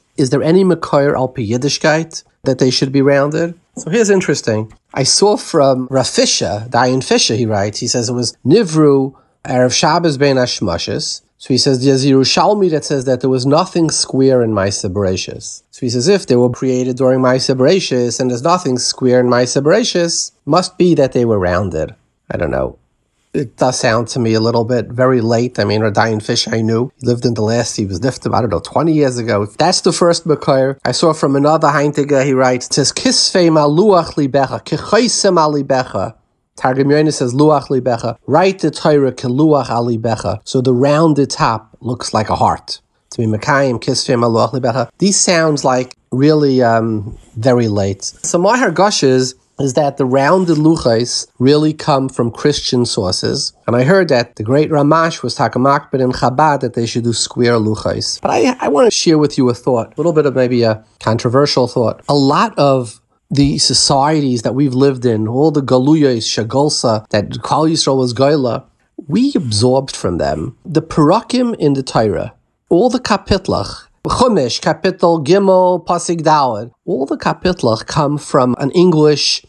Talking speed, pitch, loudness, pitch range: 180 wpm, 135 Hz, -14 LUFS, 120-155 Hz